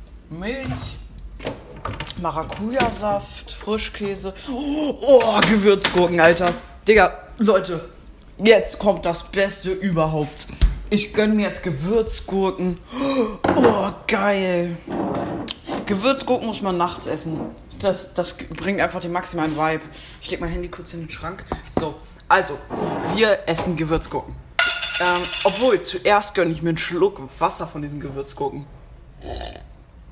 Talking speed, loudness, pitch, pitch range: 115 wpm, -21 LUFS, 185 Hz, 165-210 Hz